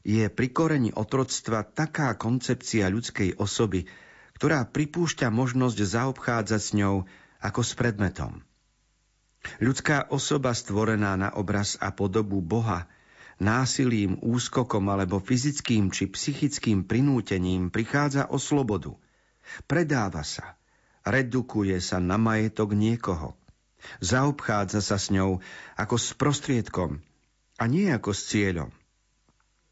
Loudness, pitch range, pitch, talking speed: -26 LUFS, 100-130 Hz, 110 Hz, 110 wpm